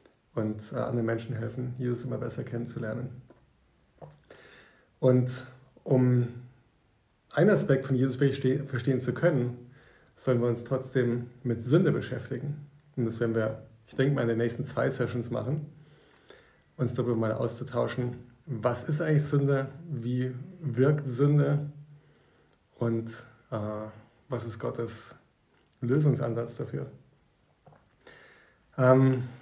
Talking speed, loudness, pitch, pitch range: 115 wpm, -29 LUFS, 125 Hz, 120-135 Hz